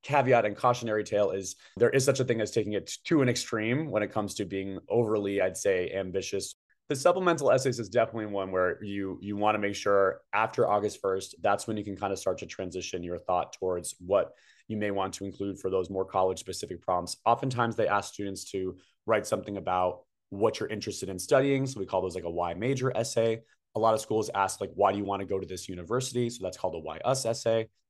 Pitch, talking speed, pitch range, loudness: 100 Hz, 230 wpm, 95-115 Hz, -29 LUFS